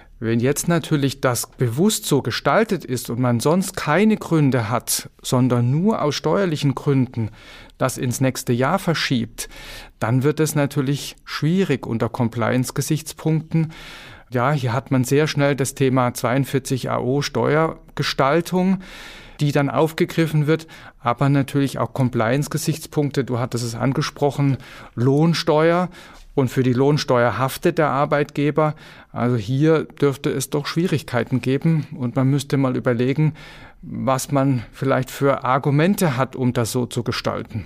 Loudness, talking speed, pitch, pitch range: -20 LUFS, 135 wpm, 140 Hz, 125-155 Hz